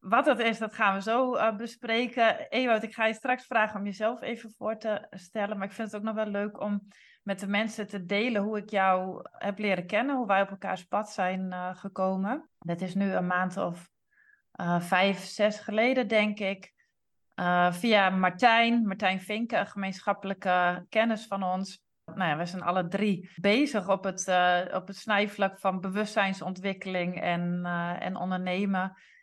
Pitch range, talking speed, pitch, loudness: 185-220 Hz, 185 wpm, 200 Hz, -29 LUFS